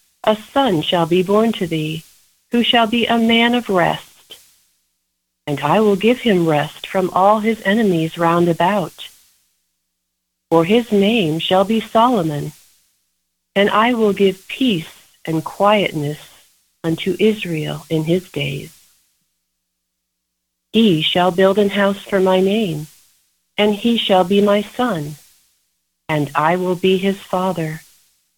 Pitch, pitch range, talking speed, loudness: 180 Hz, 150-210 Hz, 135 wpm, -17 LUFS